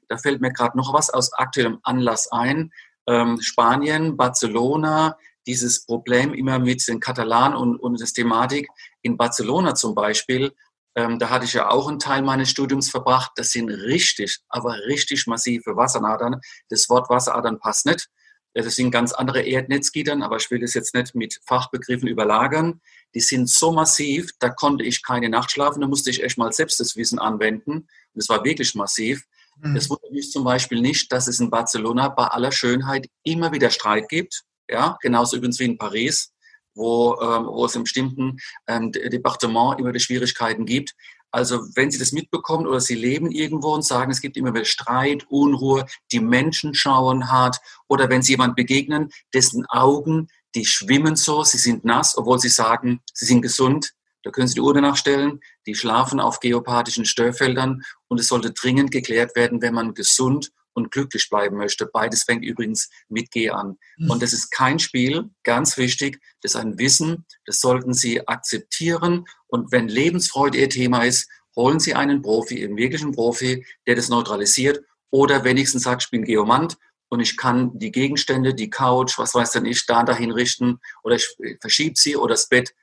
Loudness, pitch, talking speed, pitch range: -20 LUFS, 125 Hz, 180 wpm, 120-140 Hz